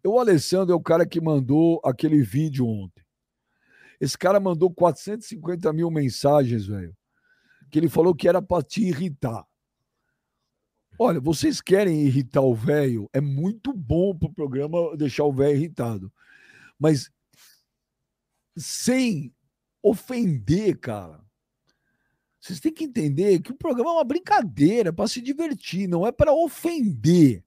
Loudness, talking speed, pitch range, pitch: -23 LUFS, 140 wpm, 140-200 Hz, 165 Hz